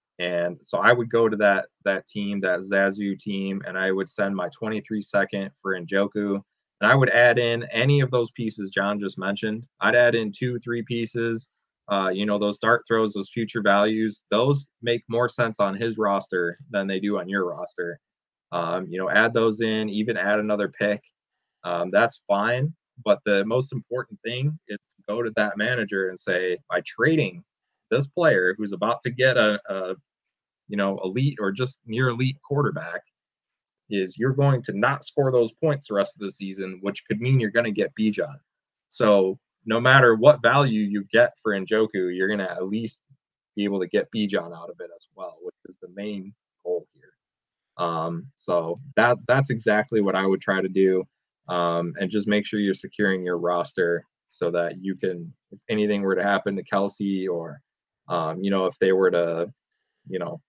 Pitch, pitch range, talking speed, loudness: 105 Hz, 95-120 Hz, 195 wpm, -24 LUFS